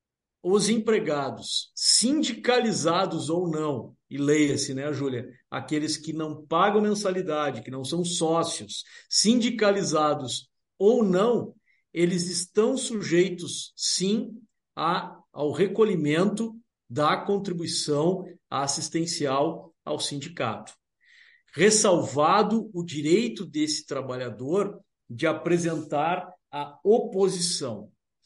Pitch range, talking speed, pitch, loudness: 150-205 Hz, 90 wpm, 170 Hz, -25 LUFS